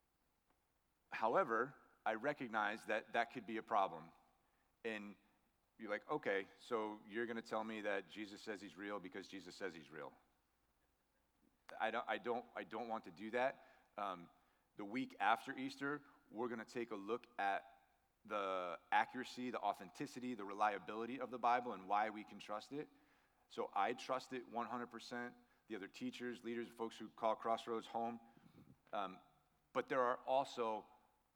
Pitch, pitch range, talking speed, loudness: 115 Hz, 105-125 Hz, 165 wpm, -44 LUFS